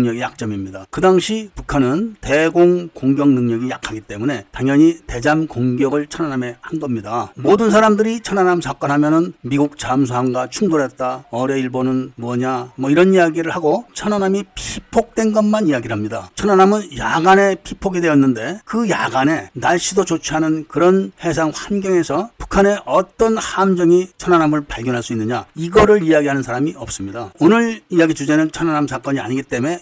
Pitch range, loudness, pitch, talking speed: 130-185 Hz, -17 LUFS, 155 Hz, 375 characters per minute